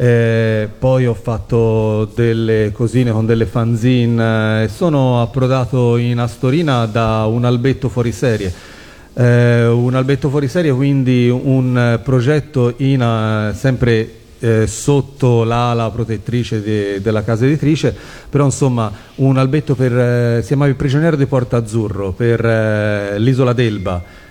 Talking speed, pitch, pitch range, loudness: 135 wpm, 120 Hz, 110-130 Hz, -15 LUFS